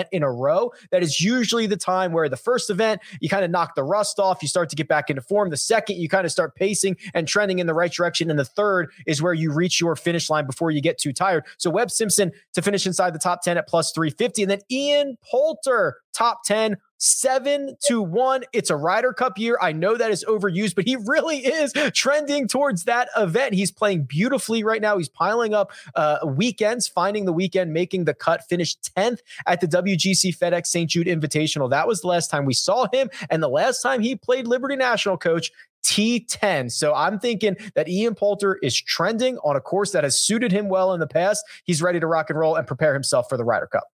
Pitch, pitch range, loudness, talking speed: 195 Hz, 170-225 Hz, -21 LUFS, 230 wpm